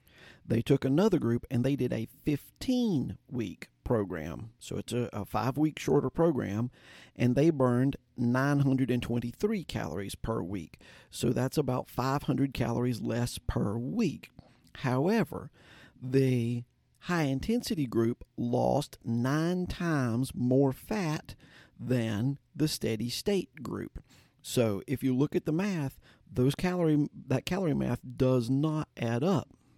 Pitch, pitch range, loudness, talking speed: 130 Hz, 120-150 Hz, -31 LUFS, 130 wpm